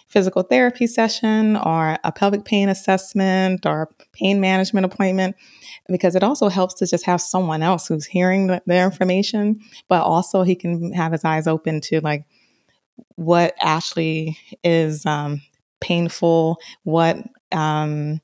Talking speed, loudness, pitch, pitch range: 145 wpm, -19 LUFS, 185 Hz, 160-195 Hz